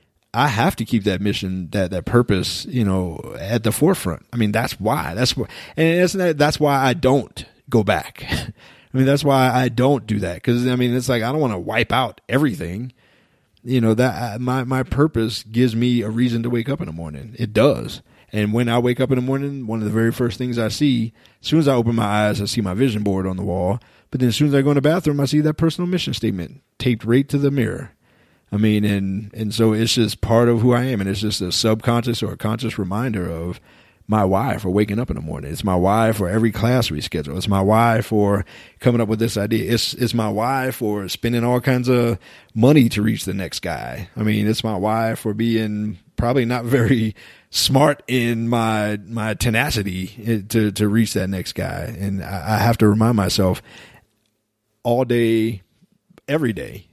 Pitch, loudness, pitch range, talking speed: 115 Hz, -19 LUFS, 105-125 Hz, 220 wpm